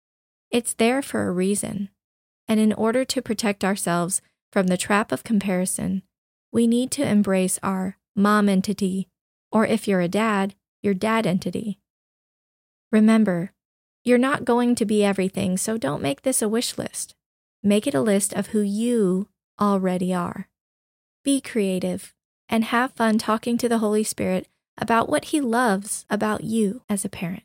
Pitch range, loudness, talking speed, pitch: 195-230 Hz, -23 LUFS, 160 wpm, 210 Hz